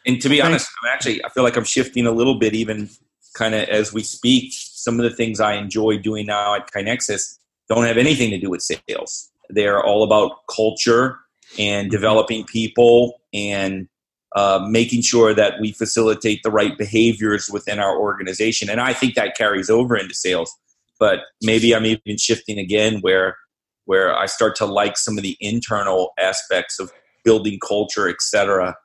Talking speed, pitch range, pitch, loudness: 180 wpm, 105-115 Hz, 110 Hz, -18 LUFS